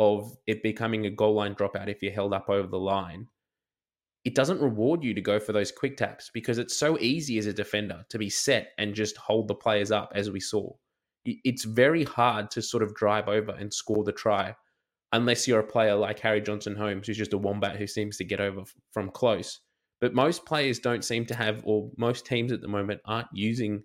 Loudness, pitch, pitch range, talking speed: -28 LUFS, 105 Hz, 100-115 Hz, 225 wpm